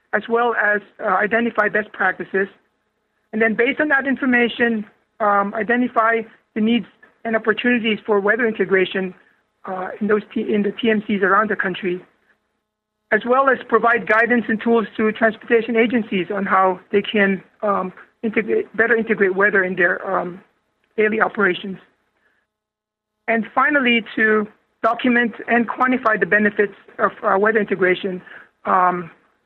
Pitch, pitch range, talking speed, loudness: 215 Hz, 200-230 Hz, 140 wpm, -18 LUFS